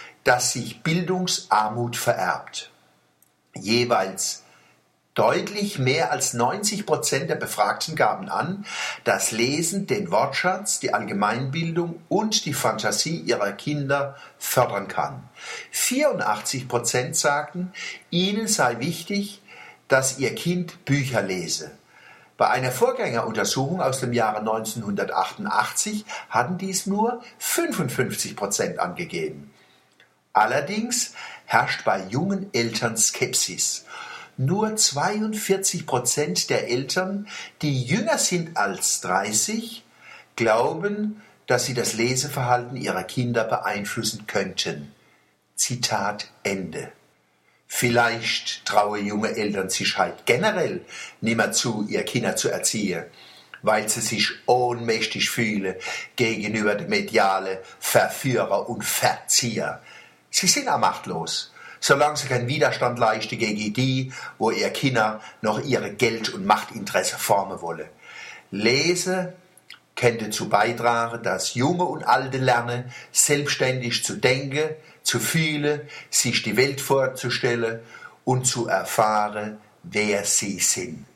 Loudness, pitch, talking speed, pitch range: -23 LUFS, 130 Hz, 110 wpm, 115-180 Hz